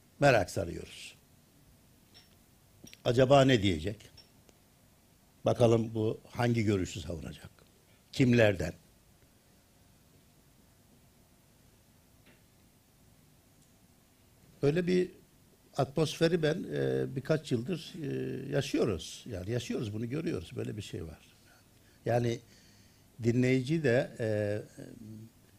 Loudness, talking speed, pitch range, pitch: -31 LUFS, 75 wpm, 105-130 Hz, 120 Hz